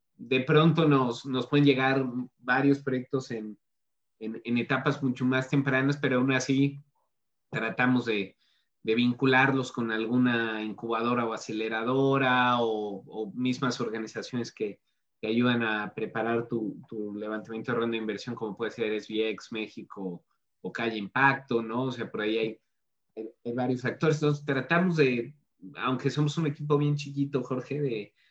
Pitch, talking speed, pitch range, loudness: 125 Hz, 155 wpm, 110-135 Hz, -28 LUFS